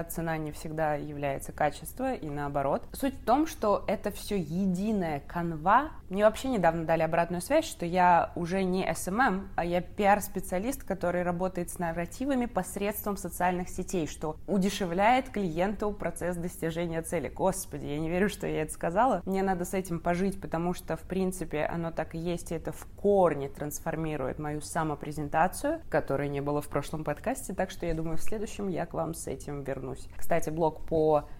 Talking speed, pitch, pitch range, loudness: 175 wpm, 175 Hz, 160-195 Hz, -30 LUFS